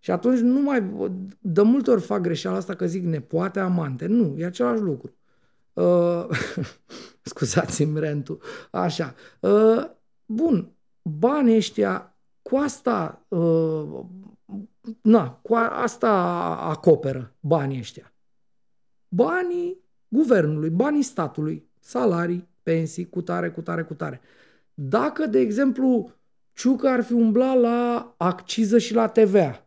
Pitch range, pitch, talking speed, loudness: 155-235 Hz, 190 Hz, 125 wpm, -23 LUFS